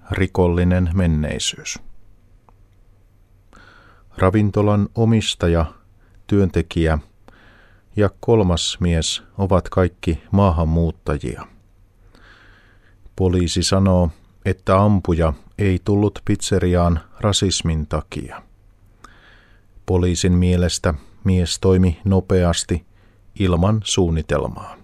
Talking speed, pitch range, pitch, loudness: 65 wpm, 90-100 Hz, 95 Hz, -19 LUFS